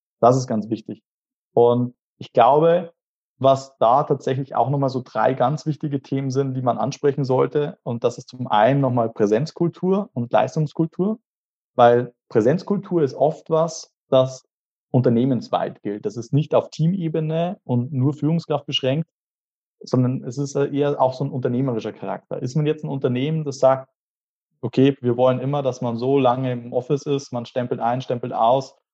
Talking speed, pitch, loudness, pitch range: 165 wpm, 135 Hz, -21 LUFS, 125-150 Hz